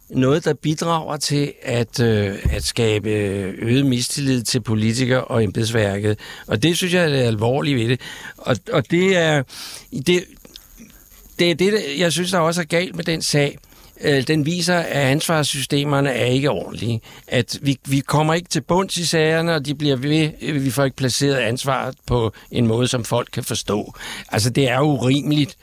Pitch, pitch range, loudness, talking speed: 140 Hz, 120-155 Hz, -19 LUFS, 180 wpm